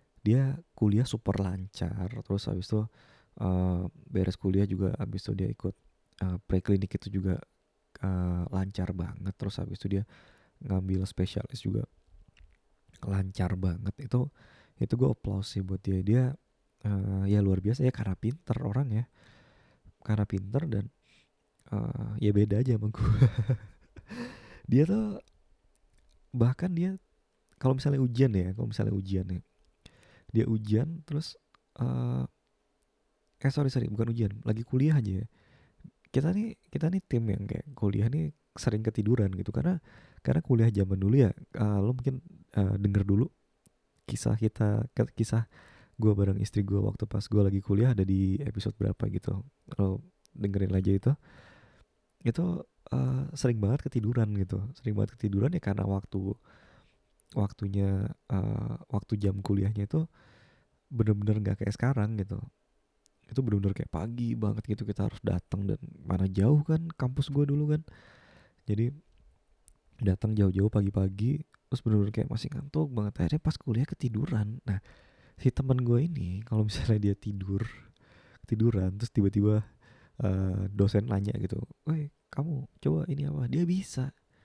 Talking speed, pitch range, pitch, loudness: 145 wpm, 100-130 Hz, 105 Hz, -30 LUFS